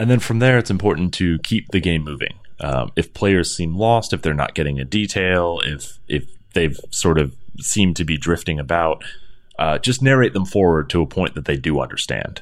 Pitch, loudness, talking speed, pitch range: 85 Hz, -19 LUFS, 215 wpm, 80-105 Hz